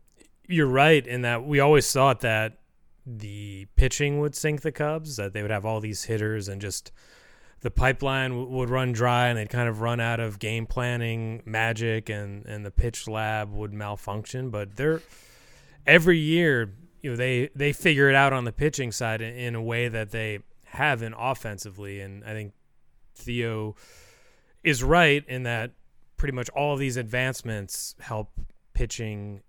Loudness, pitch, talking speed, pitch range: -25 LUFS, 120 Hz, 175 wpm, 110-135 Hz